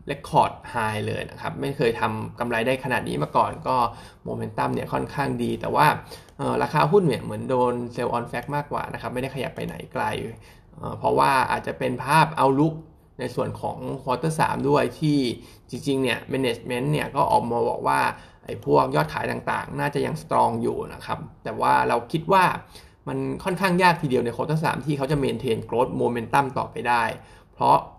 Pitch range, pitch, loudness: 120-145 Hz, 130 Hz, -24 LUFS